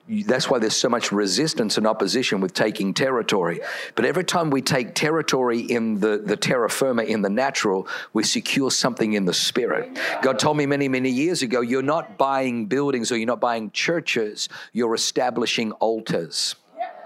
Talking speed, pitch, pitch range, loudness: 175 wpm, 130 Hz, 115-155 Hz, -22 LUFS